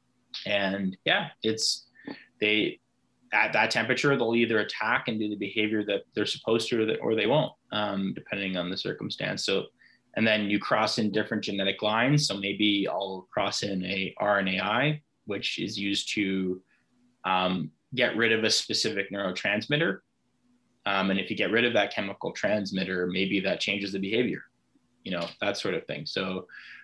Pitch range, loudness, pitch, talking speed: 95-110 Hz, -27 LUFS, 105 Hz, 170 wpm